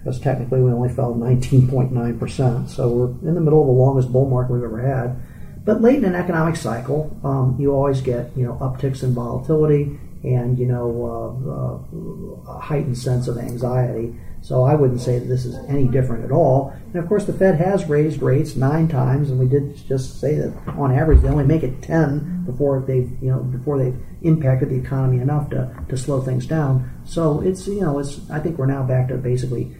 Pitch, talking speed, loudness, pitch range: 130 Hz, 215 wpm, -20 LUFS, 125-145 Hz